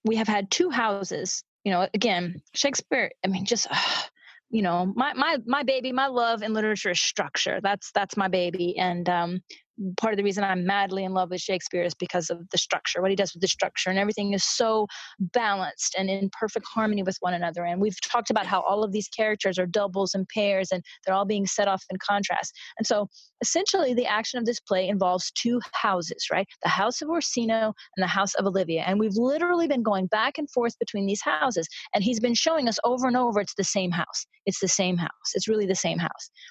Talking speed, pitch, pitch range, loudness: 225 wpm, 200 Hz, 185-235 Hz, -26 LUFS